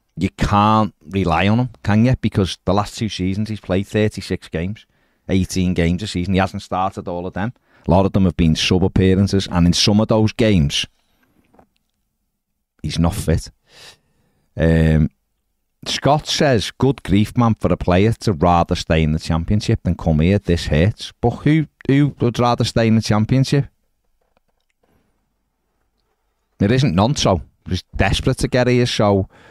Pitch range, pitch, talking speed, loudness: 85-110 Hz, 95 Hz, 165 wpm, -18 LUFS